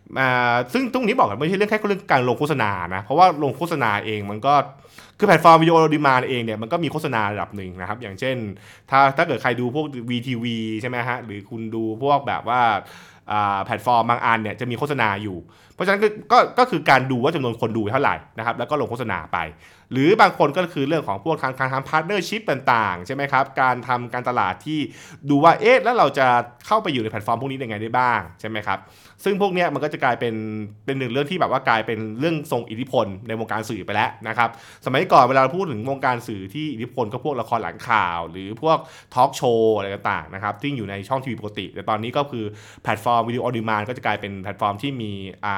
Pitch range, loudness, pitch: 110-150 Hz, -21 LUFS, 125 Hz